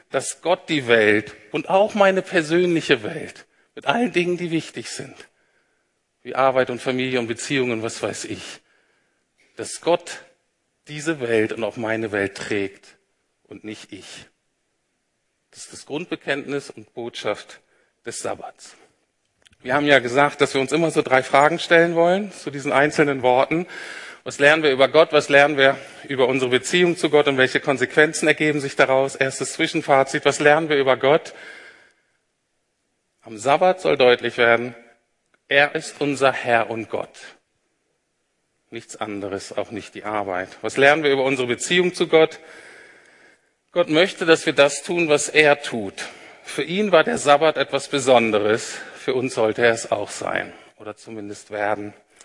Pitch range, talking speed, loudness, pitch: 120-160 Hz, 160 wpm, -19 LUFS, 140 Hz